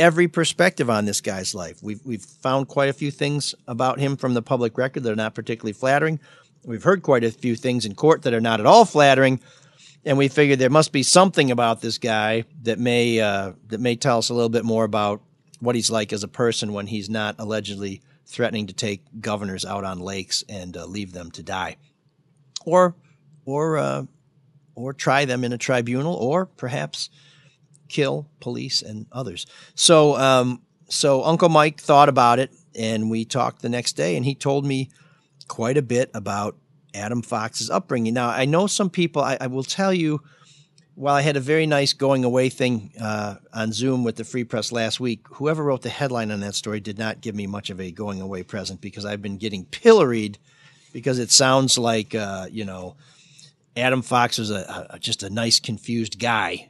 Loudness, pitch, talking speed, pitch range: -21 LUFS, 125 Hz, 200 wpm, 110-145 Hz